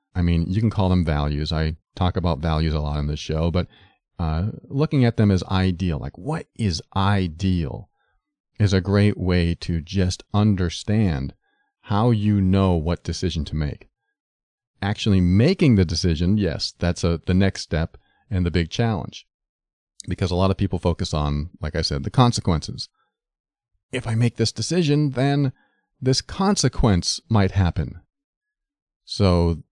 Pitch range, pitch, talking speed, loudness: 85-115 Hz, 95 Hz, 160 wpm, -22 LUFS